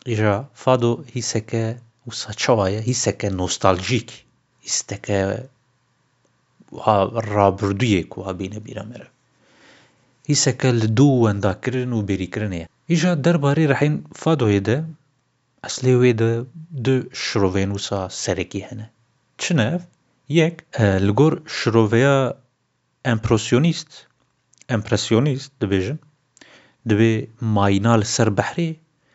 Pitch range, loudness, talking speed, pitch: 105-135 Hz, -20 LUFS, 80 wpm, 120 Hz